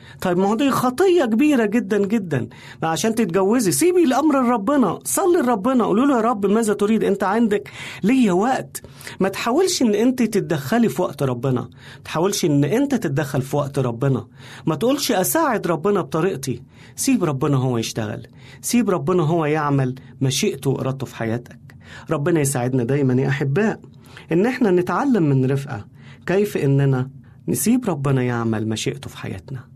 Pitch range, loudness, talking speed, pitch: 130-220 Hz, -20 LUFS, 150 wpm, 160 Hz